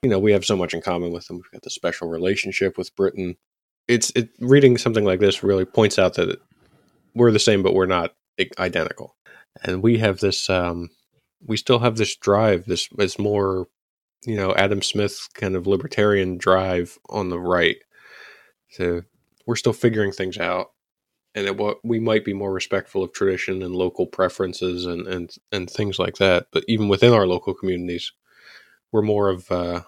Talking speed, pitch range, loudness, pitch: 190 wpm, 90-105 Hz, -21 LUFS, 95 Hz